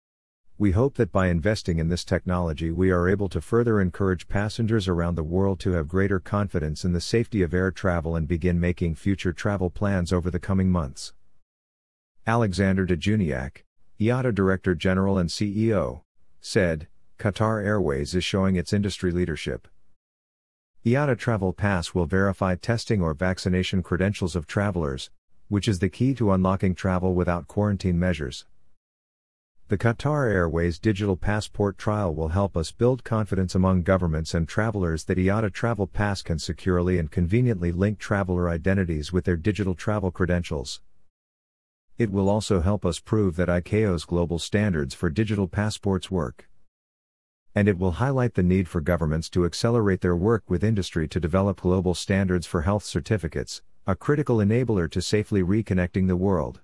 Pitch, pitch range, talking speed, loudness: 95 Hz, 85-105 Hz, 155 wpm, -25 LUFS